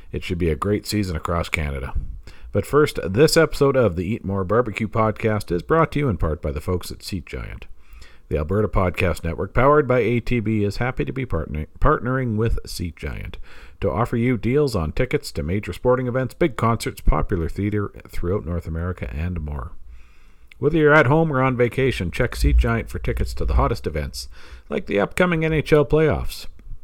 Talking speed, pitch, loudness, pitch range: 190 wpm, 100 Hz, -22 LUFS, 85-125 Hz